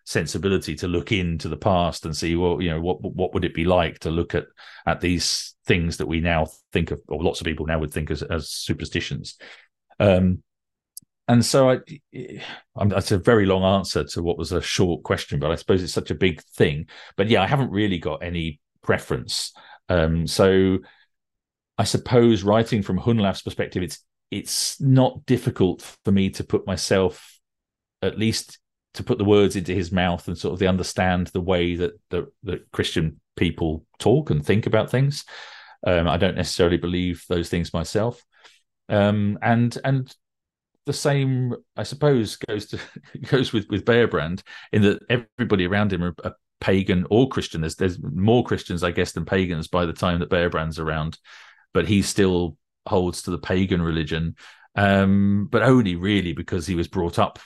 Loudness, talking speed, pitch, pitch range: -22 LUFS, 180 wpm, 95 Hz, 85-105 Hz